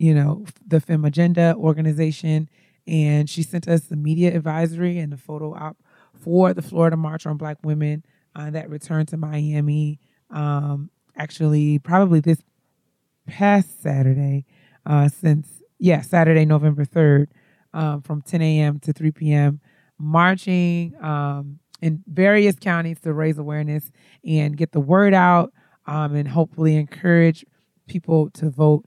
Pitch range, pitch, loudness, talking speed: 150-170 Hz, 155 Hz, -20 LUFS, 140 wpm